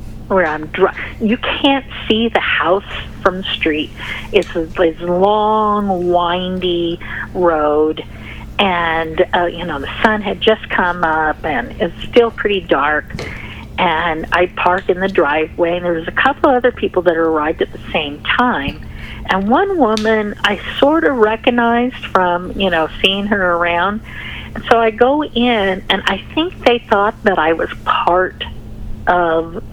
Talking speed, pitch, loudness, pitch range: 155 wpm, 185 Hz, -15 LUFS, 170-220 Hz